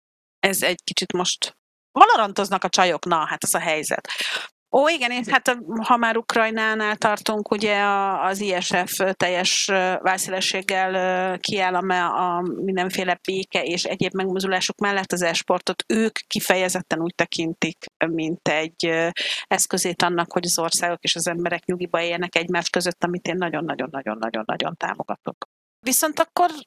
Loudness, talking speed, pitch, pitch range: -22 LUFS, 135 wpm, 185 Hz, 175-200 Hz